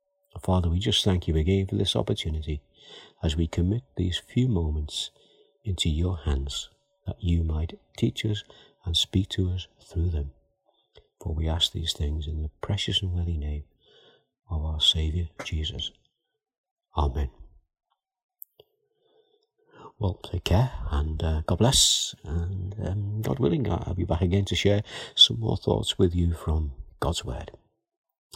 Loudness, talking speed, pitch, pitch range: -26 LUFS, 150 wpm, 90 Hz, 80-100 Hz